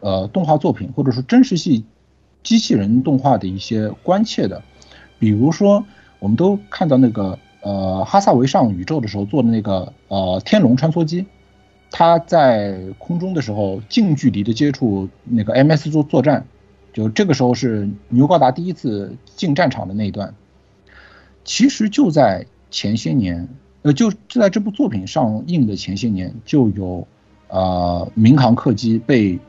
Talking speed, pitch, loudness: 245 characters per minute, 125 Hz, -17 LUFS